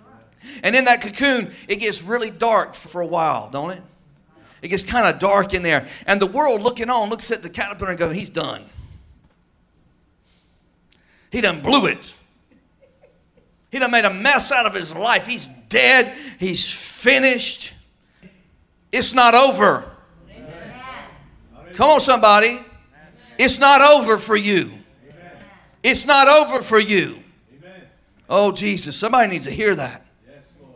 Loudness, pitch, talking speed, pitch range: -16 LUFS, 210 Hz, 140 wpm, 175-250 Hz